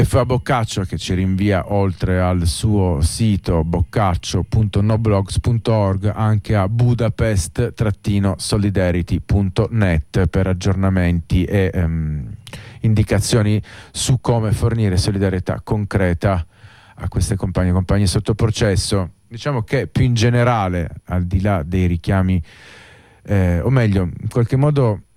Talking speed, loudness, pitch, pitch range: 110 wpm, -18 LUFS, 100 Hz, 95-115 Hz